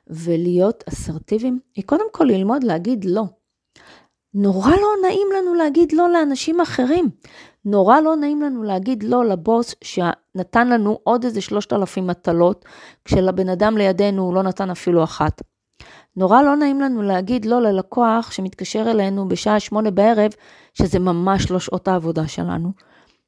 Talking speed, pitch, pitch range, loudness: 145 wpm, 210 Hz, 185-250 Hz, -18 LUFS